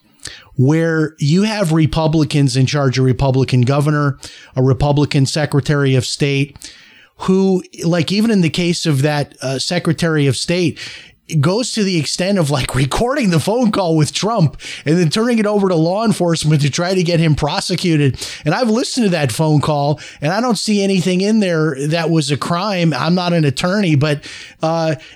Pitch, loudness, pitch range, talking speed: 160 Hz, -15 LUFS, 145-180 Hz, 180 wpm